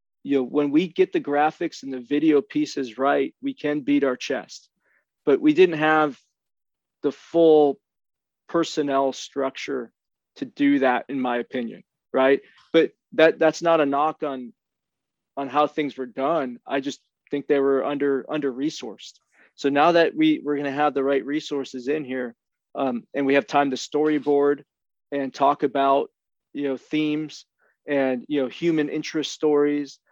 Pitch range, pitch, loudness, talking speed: 135-155 Hz, 145 Hz, -23 LUFS, 165 wpm